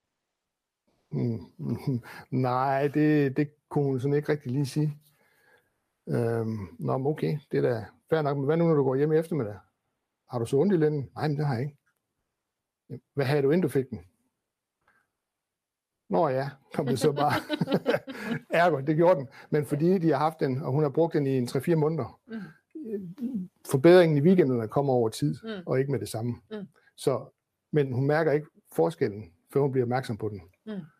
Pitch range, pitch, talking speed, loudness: 130-165 Hz, 145 Hz, 180 wpm, -27 LUFS